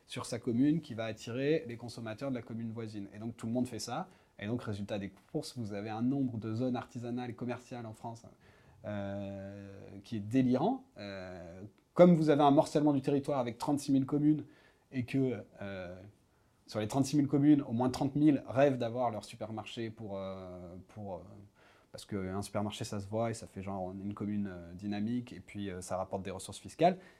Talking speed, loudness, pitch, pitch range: 205 wpm, -34 LUFS, 115 Hz, 100-130 Hz